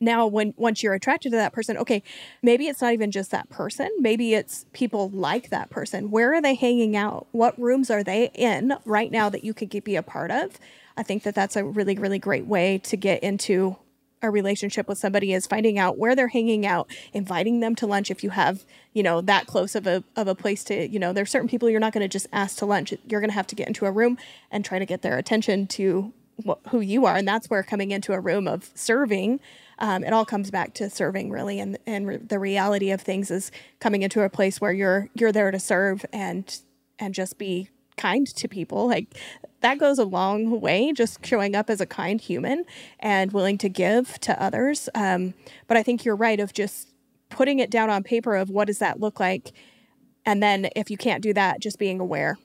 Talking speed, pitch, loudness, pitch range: 235 wpm, 210 Hz, -24 LUFS, 195-230 Hz